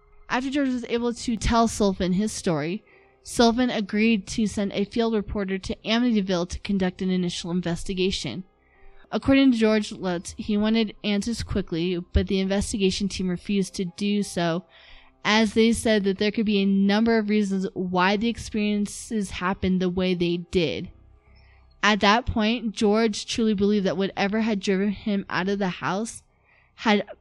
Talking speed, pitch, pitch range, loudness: 165 wpm, 200 Hz, 185-220 Hz, -24 LUFS